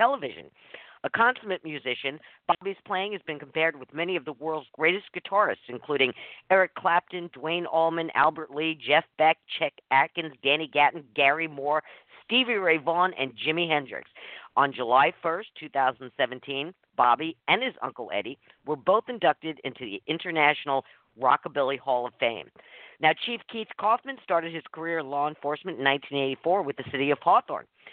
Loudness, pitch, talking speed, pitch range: -26 LUFS, 155 Hz, 165 wpm, 140-175 Hz